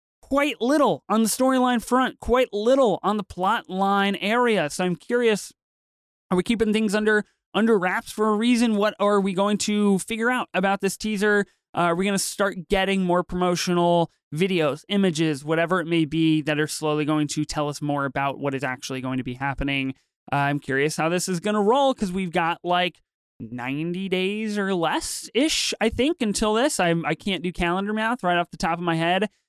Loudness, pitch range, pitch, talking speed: -23 LUFS, 160-215 Hz, 185 Hz, 210 wpm